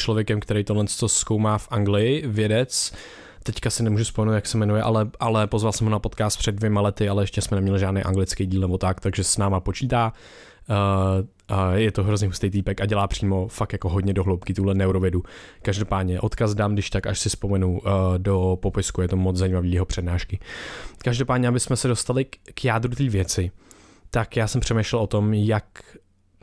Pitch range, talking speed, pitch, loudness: 95-110 Hz, 200 wpm, 100 Hz, -23 LUFS